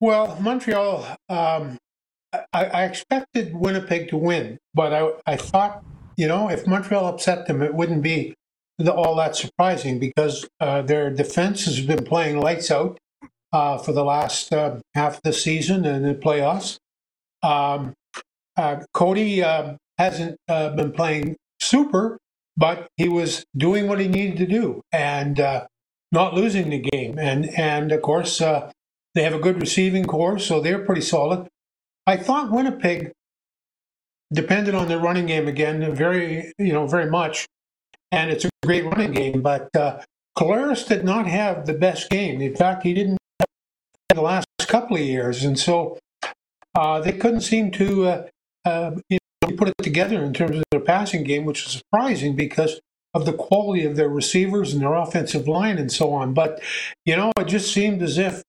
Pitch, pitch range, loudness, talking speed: 165 Hz, 150-190 Hz, -22 LUFS, 175 wpm